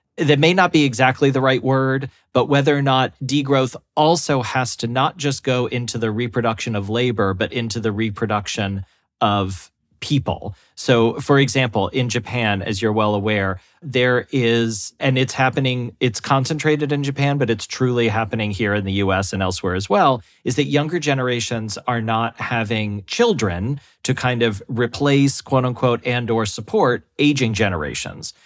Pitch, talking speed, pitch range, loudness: 120 Hz, 165 wpm, 110-135 Hz, -19 LUFS